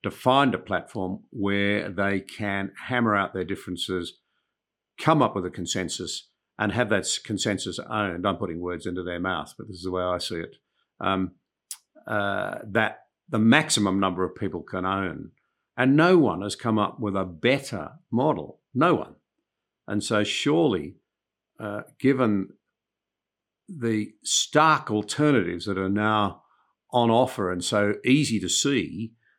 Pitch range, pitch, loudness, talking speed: 95-110 Hz, 100 Hz, -25 LUFS, 155 wpm